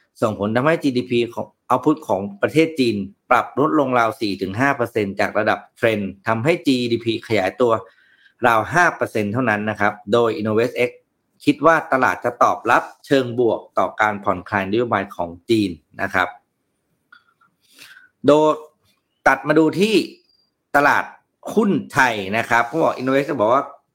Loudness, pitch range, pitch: -19 LUFS, 105-155 Hz, 120 Hz